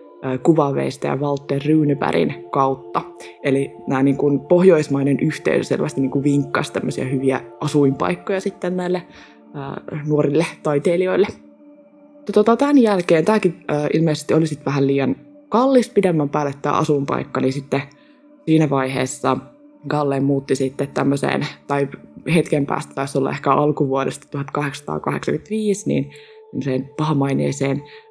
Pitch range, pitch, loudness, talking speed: 135-180 Hz, 145 Hz, -19 LUFS, 115 wpm